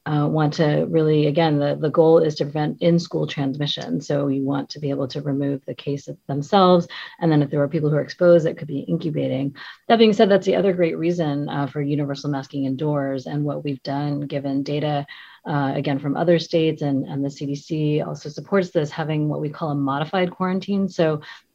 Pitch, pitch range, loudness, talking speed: 150 Hz, 140-165 Hz, -21 LUFS, 215 wpm